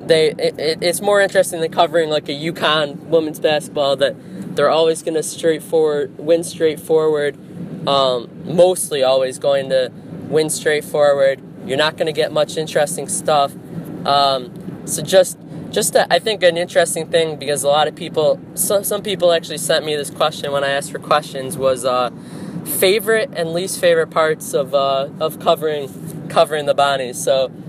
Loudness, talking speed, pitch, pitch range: -17 LUFS, 175 wpm, 160 Hz, 145-175 Hz